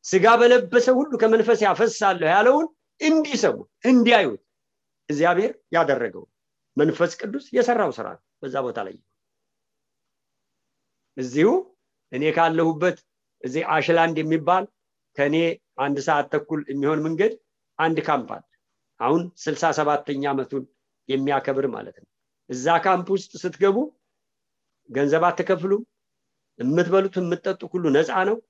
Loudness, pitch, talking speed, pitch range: -22 LUFS, 180 Hz, 105 wpm, 155-230 Hz